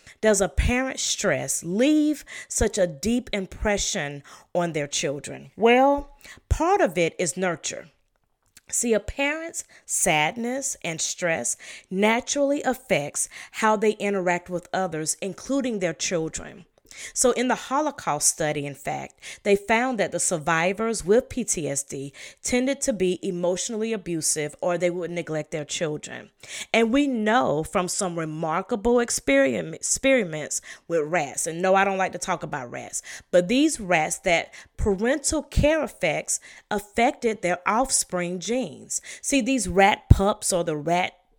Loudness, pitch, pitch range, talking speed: -24 LUFS, 195 Hz, 170-245 Hz, 140 wpm